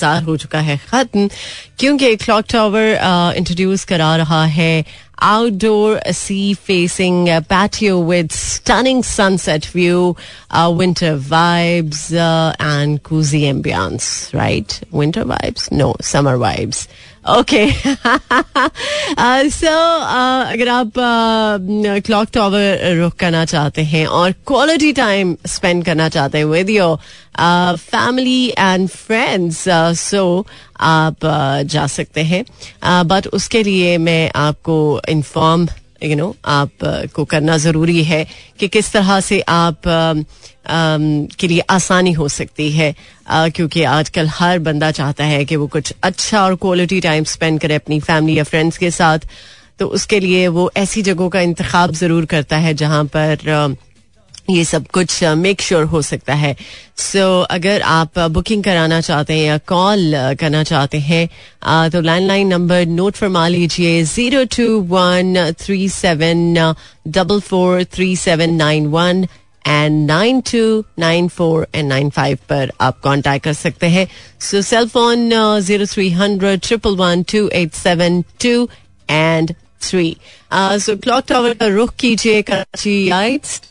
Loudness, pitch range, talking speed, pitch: -14 LUFS, 160-200 Hz, 140 wpm, 175 Hz